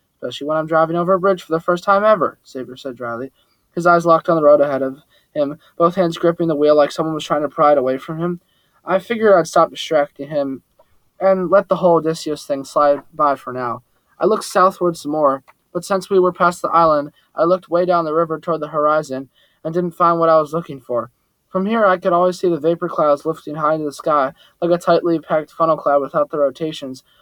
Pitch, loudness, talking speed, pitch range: 160 Hz, -17 LUFS, 235 wpm, 145-175 Hz